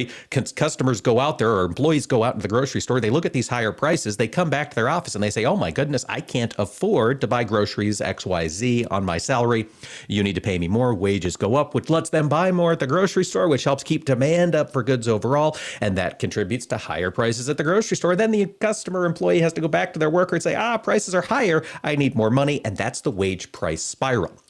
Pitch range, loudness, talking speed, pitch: 110-160 Hz, -22 LUFS, 250 wpm, 130 Hz